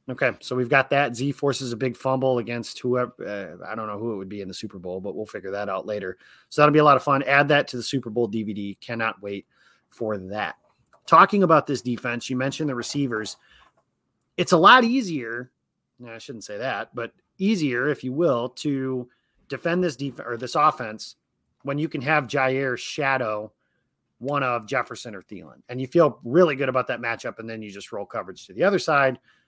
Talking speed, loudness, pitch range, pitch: 215 wpm, -23 LUFS, 115-140 Hz, 125 Hz